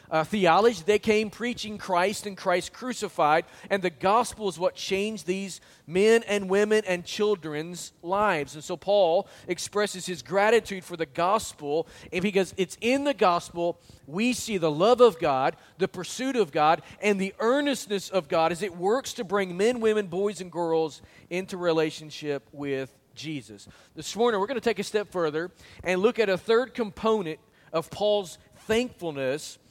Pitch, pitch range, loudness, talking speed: 190 Hz, 165-210 Hz, -26 LUFS, 170 wpm